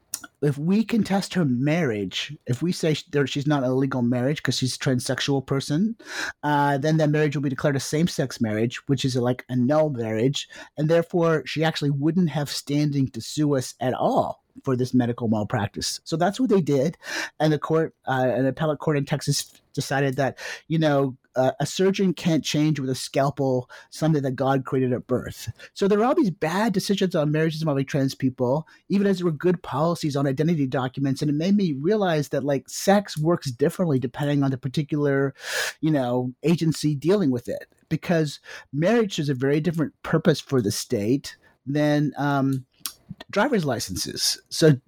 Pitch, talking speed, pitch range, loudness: 145 Hz, 185 wpm, 135-160 Hz, -24 LUFS